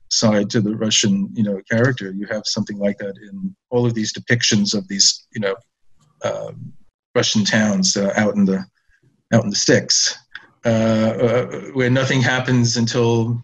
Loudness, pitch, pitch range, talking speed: -18 LUFS, 110 Hz, 100-120 Hz, 170 wpm